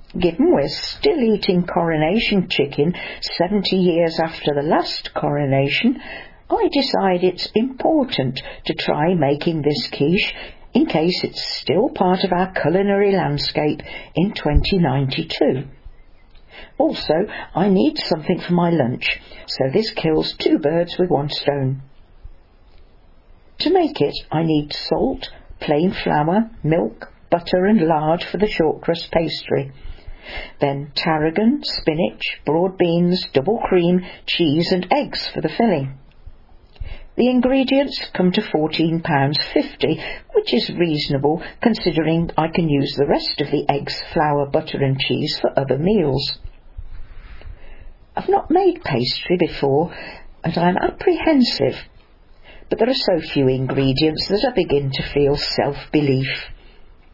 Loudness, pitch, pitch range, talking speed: -19 LUFS, 165 Hz, 140-195 Hz, 130 wpm